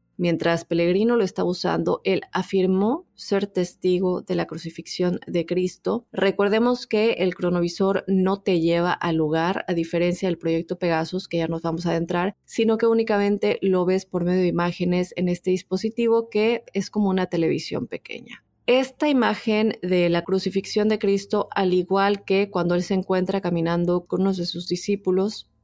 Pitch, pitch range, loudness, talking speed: 185 Hz, 175-205 Hz, -23 LUFS, 170 wpm